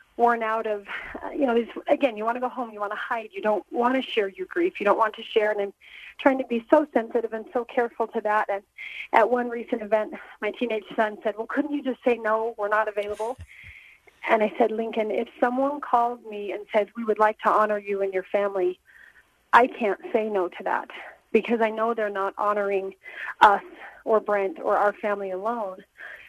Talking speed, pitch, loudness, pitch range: 220 wpm, 225 Hz, -25 LUFS, 210-245 Hz